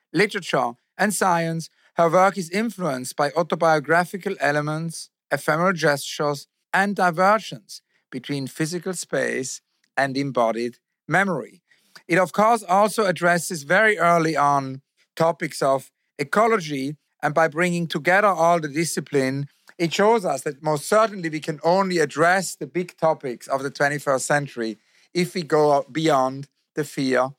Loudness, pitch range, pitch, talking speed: -22 LUFS, 145-180 Hz, 160 Hz, 135 wpm